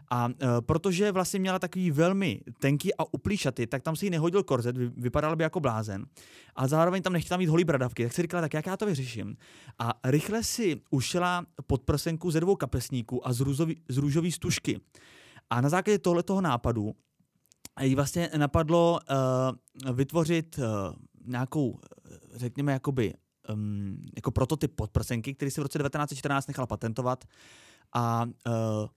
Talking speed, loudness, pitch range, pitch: 155 wpm, -29 LUFS, 125-170 Hz, 140 Hz